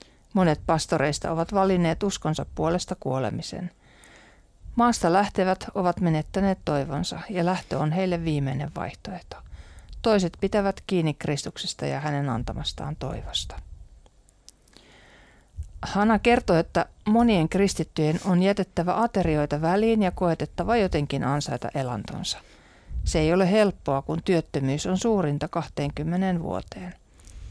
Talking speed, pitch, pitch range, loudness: 110 wpm, 165 Hz, 140-190 Hz, -25 LUFS